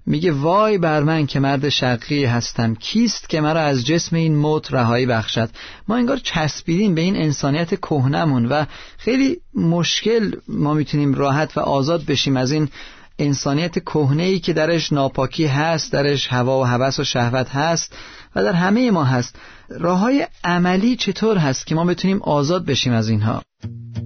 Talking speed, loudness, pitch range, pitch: 160 wpm, -19 LUFS, 135-175 Hz, 150 Hz